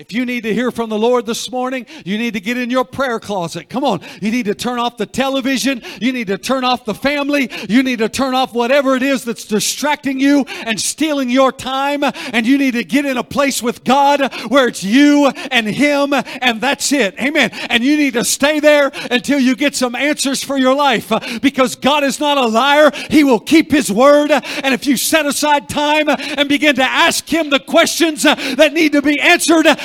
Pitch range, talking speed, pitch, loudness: 240-285 Hz, 225 wpm, 265 Hz, -14 LUFS